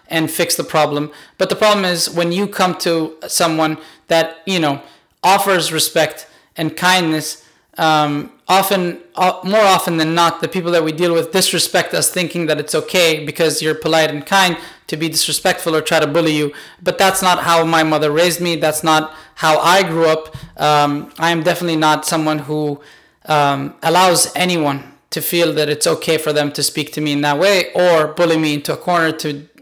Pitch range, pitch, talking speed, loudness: 155-175 Hz, 160 Hz, 195 wpm, -15 LUFS